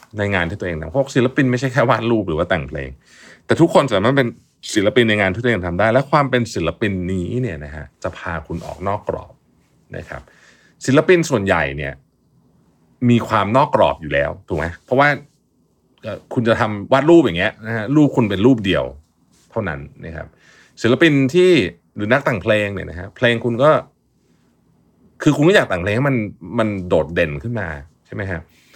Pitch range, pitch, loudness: 90-130 Hz, 110 Hz, -17 LUFS